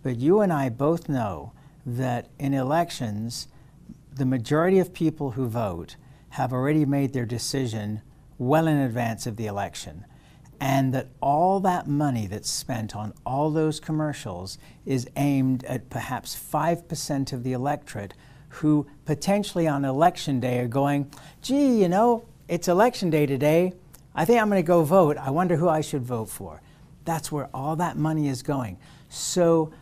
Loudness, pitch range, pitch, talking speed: -25 LUFS, 125-160 Hz, 145 Hz, 165 wpm